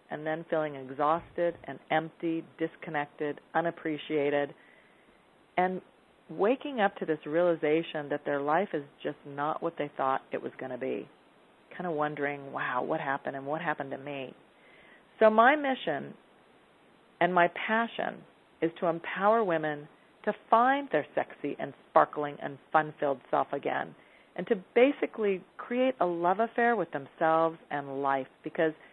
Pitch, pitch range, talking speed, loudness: 160 Hz, 145-185 Hz, 150 wpm, -30 LUFS